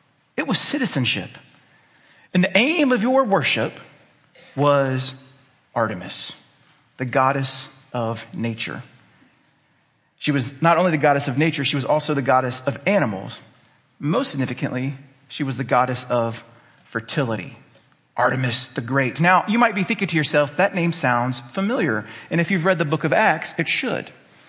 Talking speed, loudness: 150 wpm, -21 LUFS